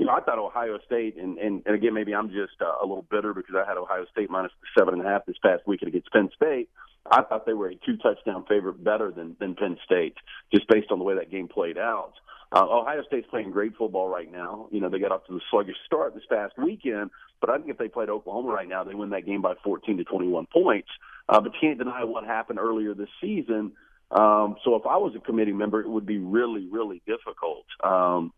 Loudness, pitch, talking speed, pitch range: -26 LUFS, 105 Hz, 250 wpm, 100-125 Hz